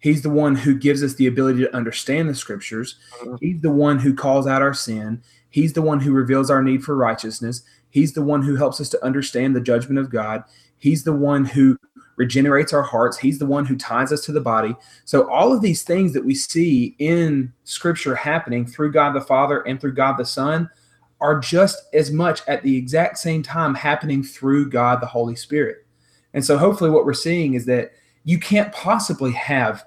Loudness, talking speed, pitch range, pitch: -19 LUFS, 210 wpm, 130-155 Hz, 140 Hz